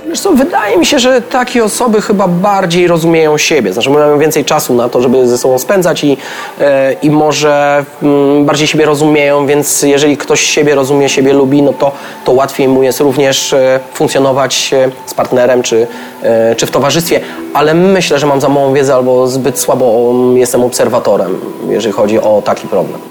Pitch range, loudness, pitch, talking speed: 130-155 Hz, -9 LUFS, 145 Hz, 170 wpm